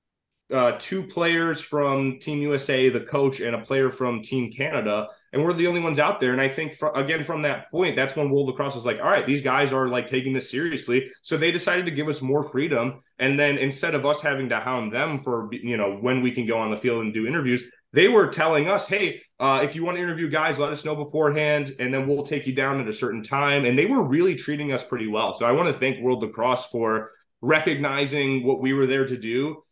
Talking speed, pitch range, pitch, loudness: 250 wpm, 125-150 Hz, 135 Hz, -23 LUFS